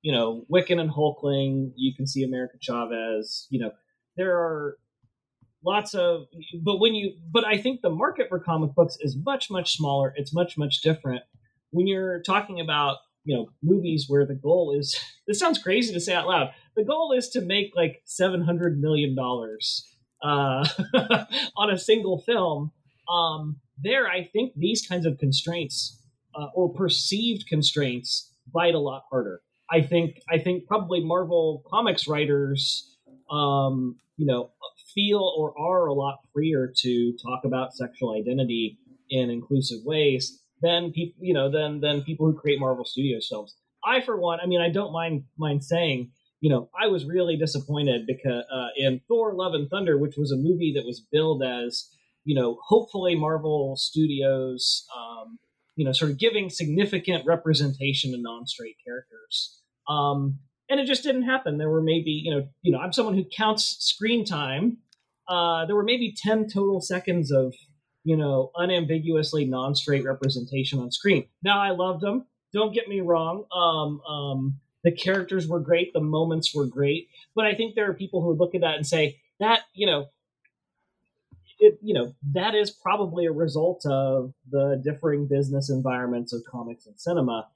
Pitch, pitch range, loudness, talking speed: 155 Hz, 135-180 Hz, -25 LUFS, 170 wpm